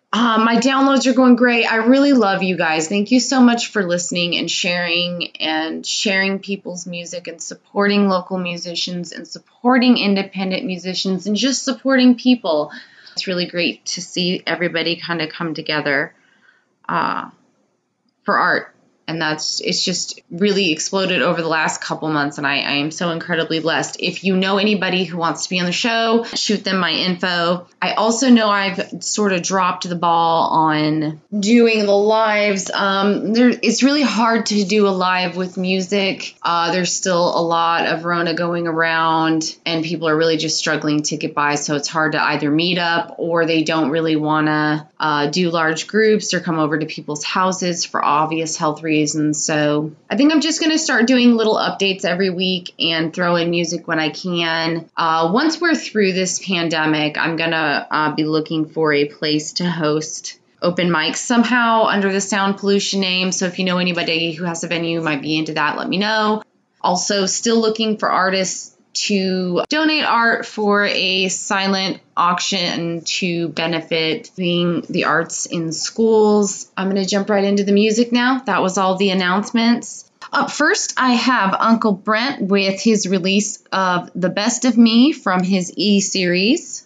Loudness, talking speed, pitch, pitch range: -17 LUFS, 180 wpm, 185 Hz, 165-210 Hz